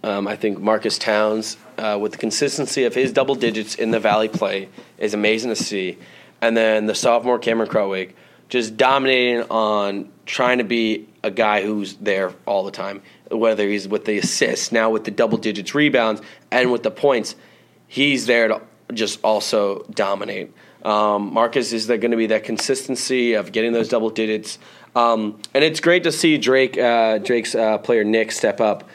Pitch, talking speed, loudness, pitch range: 110 Hz, 185 wpm, -19 LUFS, 105-120 Hz